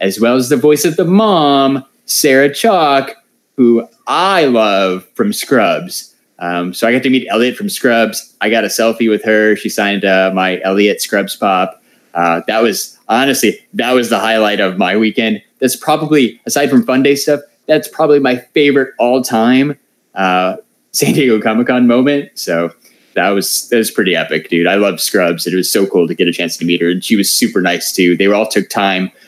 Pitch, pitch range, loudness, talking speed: 115 Hz, 95-135 Hz, -12 LUFS, 205 wpm